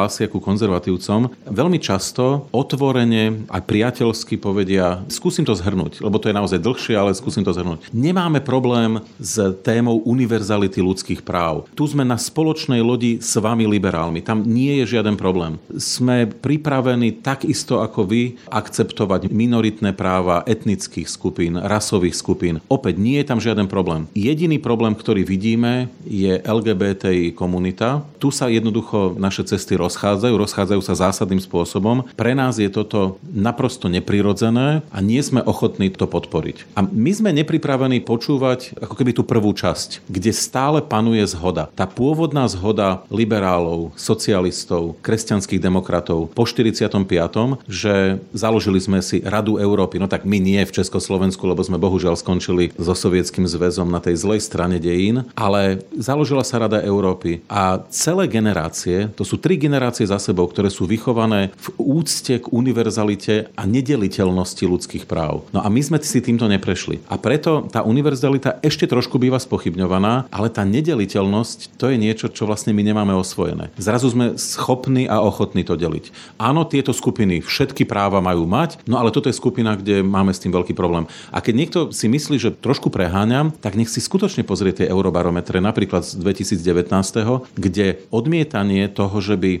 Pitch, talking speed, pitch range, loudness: 105 Hz, 155 wpm, 95-120 Hz, -19 LUFS